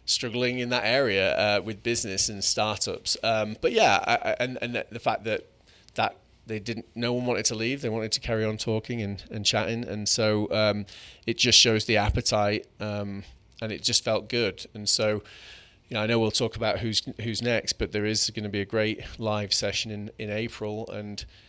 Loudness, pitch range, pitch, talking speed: -26 LUFS, 105-115 Hz, 110 Hz, 210 wpm